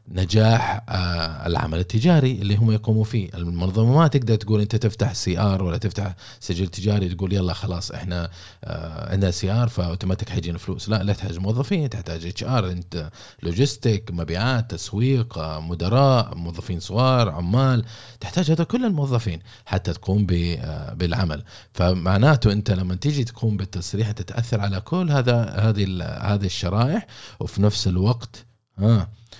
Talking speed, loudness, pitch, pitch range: 135 wpm, -22 LUFS, 105 Hz, 90-115 Hz